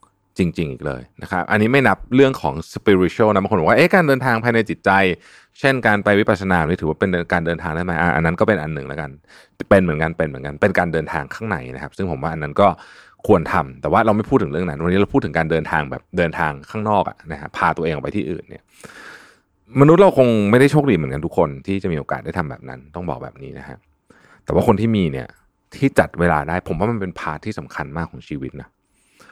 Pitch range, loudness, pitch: 80-110 Hz, -18 LUFS, 95 Hz